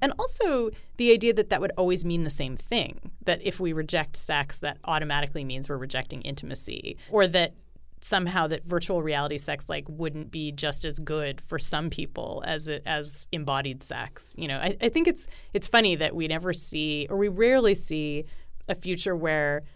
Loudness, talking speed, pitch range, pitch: -27 LUFS, 180 wpm, 150-190 Hz, 160 Hz